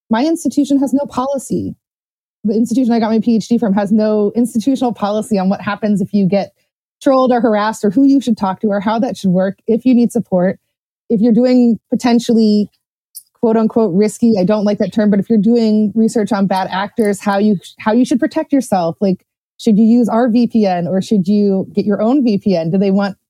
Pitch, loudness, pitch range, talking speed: 220 Hz, -14 LUFS, 200-235 Hz, 215 wpm